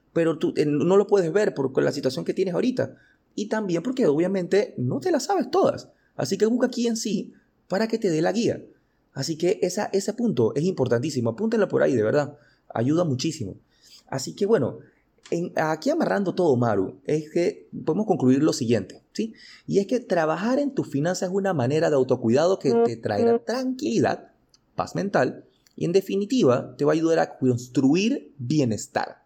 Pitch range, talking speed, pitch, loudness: 140-215 Hz, 190 wpm, 180 Hz, -24 LUFS